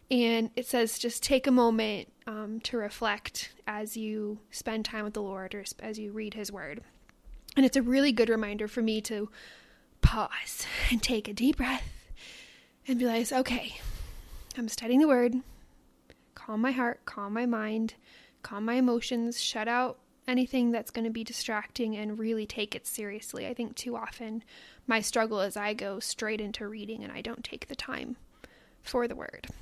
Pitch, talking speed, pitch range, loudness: 225 Hz, 180 wpm, 215-245 Hz, -31 LUFS